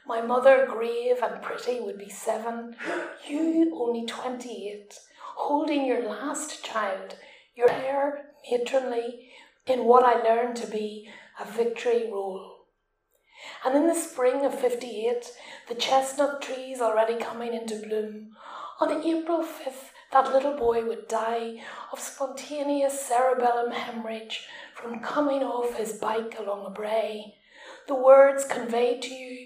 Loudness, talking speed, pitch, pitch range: -26 LUFS, 130 wpm, 250 Hz, 230-280 Hz